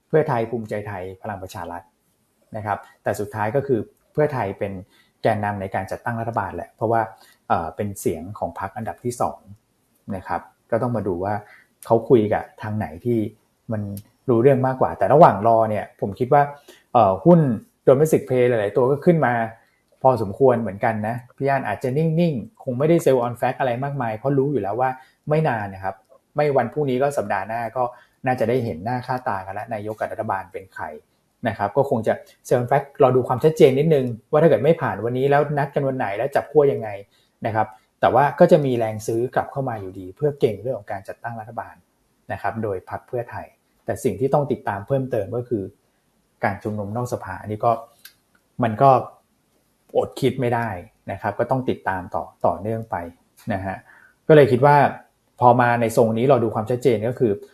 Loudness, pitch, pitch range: -21 LUFS, 120 Hz, 110-135 Hz